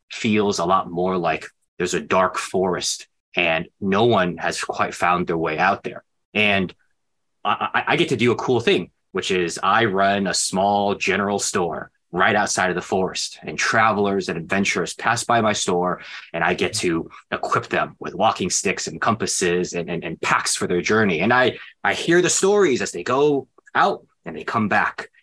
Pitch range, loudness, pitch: 90-110 Hz, -20 LUFS, 100 Hz